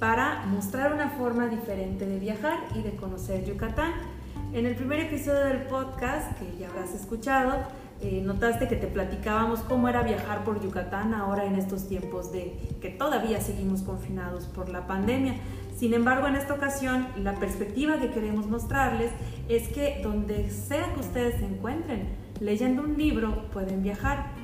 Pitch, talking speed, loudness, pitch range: 215 Hz, 160 wpm, -29 LUFS, 190-255 Hz